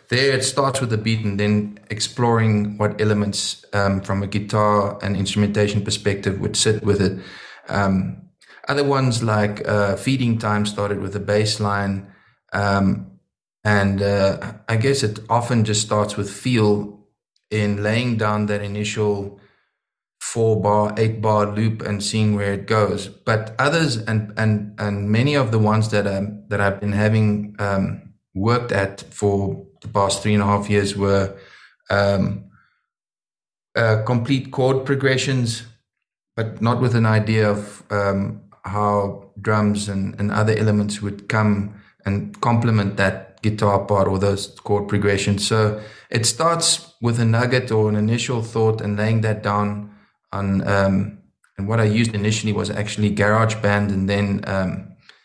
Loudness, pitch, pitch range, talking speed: -20 LUFS, 105 Hz, 100-110 Hz, 155 wpm